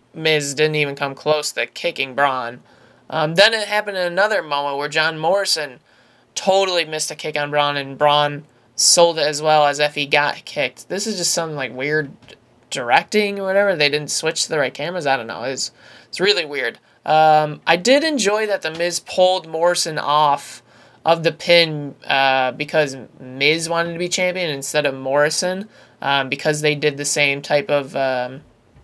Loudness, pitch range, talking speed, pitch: -18 LUFS, 145-175 Hz, 185 wpm, 155 Hz